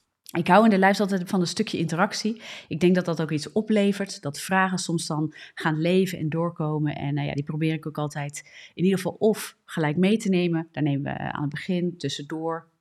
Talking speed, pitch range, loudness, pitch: 225 wpm, 150-190 Hz, -25 LUFS, 165 Hz